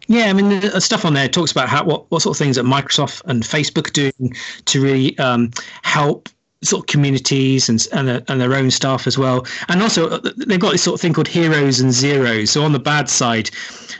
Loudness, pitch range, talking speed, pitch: -16 LUFS, 130-170 Hz, 225 wpm, 140 Hz